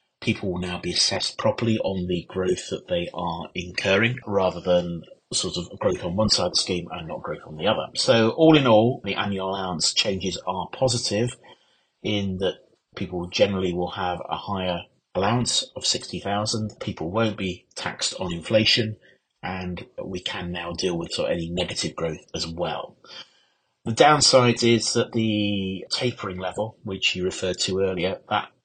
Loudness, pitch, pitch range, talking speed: -24 LUFS, 95 Hz, 90-115 Hz, 175 wpm